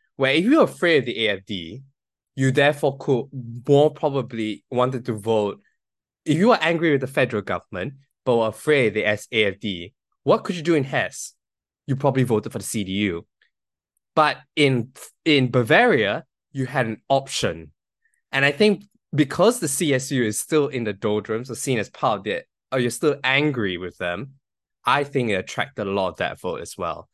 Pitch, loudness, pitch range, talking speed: 130 Hz, -22 LUFS, 110-145 Hz, 185 wpm